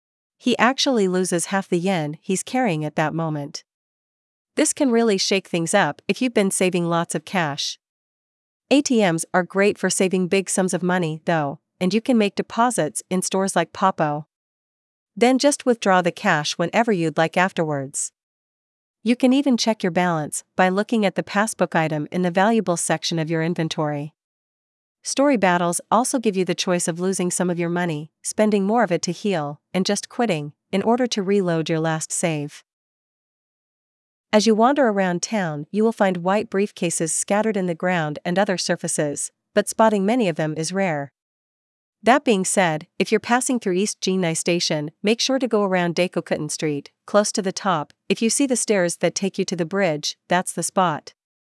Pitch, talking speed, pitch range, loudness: 185 Hz, 185 wpm, 165-210 Hz, -21 LUFS